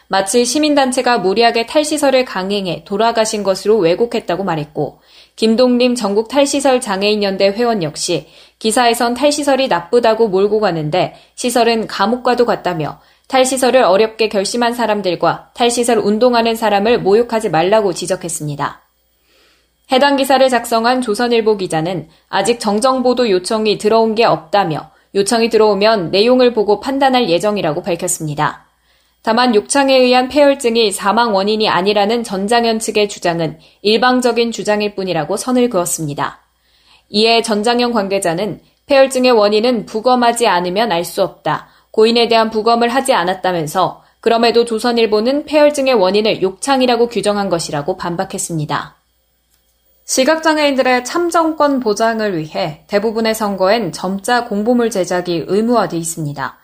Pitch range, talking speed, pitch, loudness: 190-245 Hz, 350 characters per minute, 220 Hz, -14 LUFS